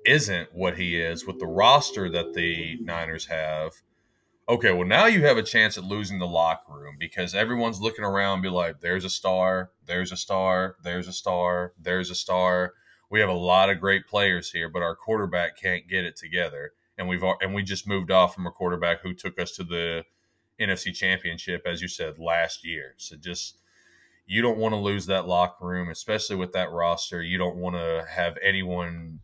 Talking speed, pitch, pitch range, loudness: 205 wpm, 90 Hz, 85-95 Hz, -25 LUFS